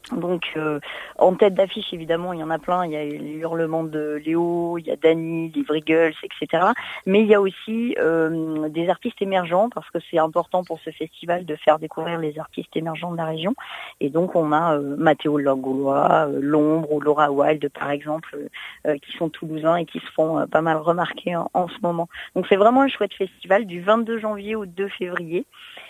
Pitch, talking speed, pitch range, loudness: 165 Hz, 210 wpm, 155-185 Hz, -22 LUFS